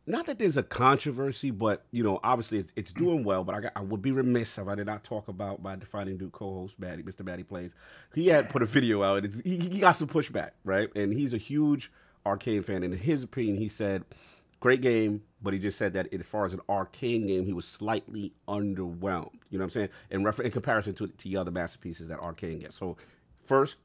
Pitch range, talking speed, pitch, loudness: 95-120 Hz, 240 wpm, 105 Hz, -30 LUFS